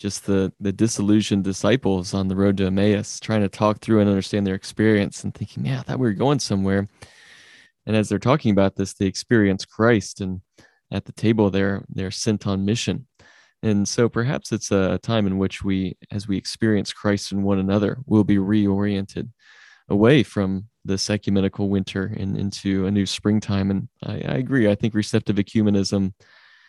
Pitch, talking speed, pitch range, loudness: 100 Hz, 185 wpm, 95-110 Hz, -22 LUFS